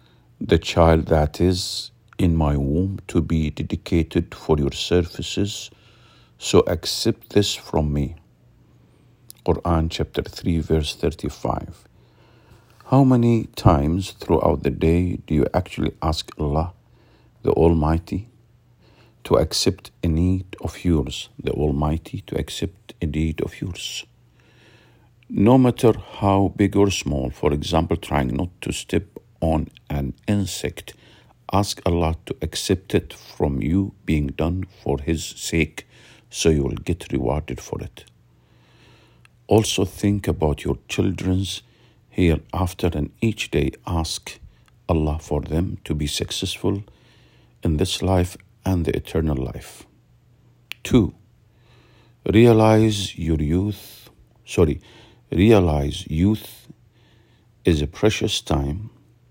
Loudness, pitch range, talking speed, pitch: -22 LUFS, 80-110 Hz, 120 wpm, 90 Hz